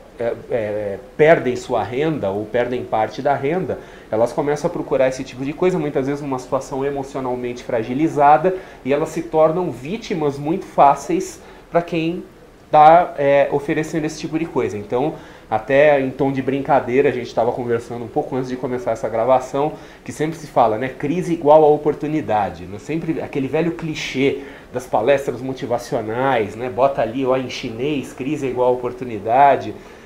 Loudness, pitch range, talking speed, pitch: -19 LUFS, 125-155 Hz, 170 wpm, 140 Hz